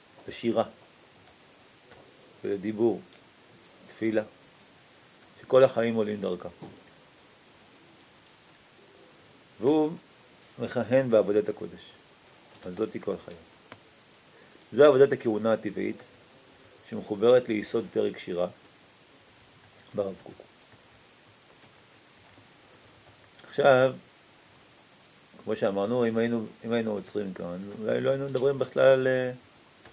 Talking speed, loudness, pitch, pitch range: 80 wpm, -27 LUFS, 115 Hz, 105-130 Hz